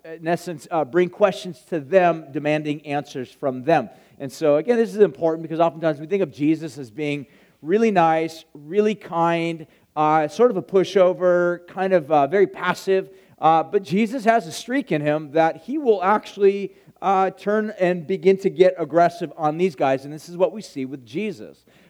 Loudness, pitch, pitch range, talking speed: -21 LUFS, 170 Hz, 155-195 Hz, 190 wpm